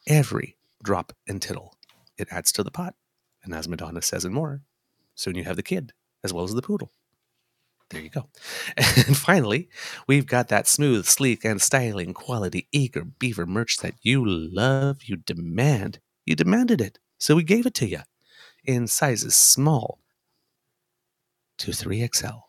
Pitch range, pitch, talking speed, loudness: 105-145 Hz, 125 Hz, 160 wpm, -22 LUFS